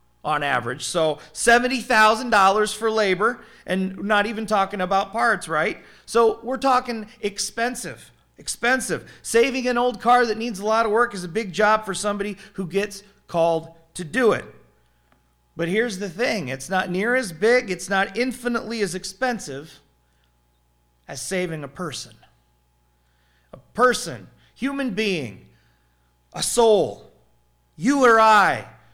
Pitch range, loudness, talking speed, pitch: 140-230 Hz, -21 LUFS, 140 wpm, 200 Hz